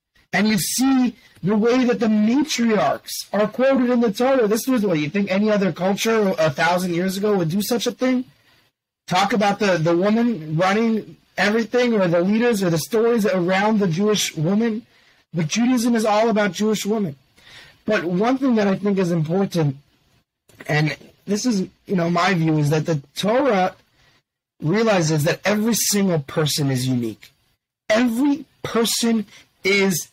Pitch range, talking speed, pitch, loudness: 165-225 Hz, 165 wpm, 200 Hz, -20 LUFS